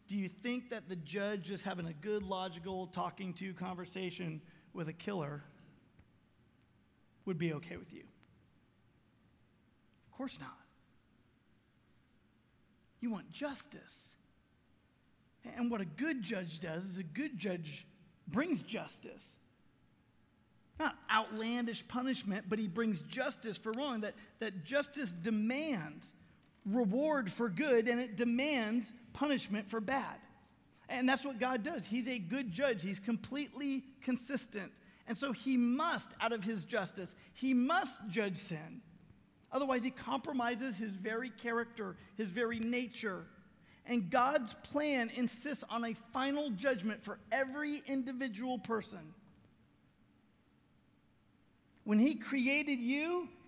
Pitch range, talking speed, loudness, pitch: 190-260 Hz, 125 wpm, -38 LUFS, 225 Hz